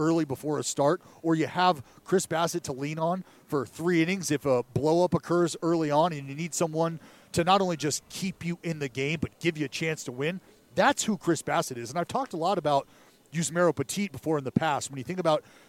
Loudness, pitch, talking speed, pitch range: -28 LUFS, 165 Hz, 240 wpm, 145-175 Hz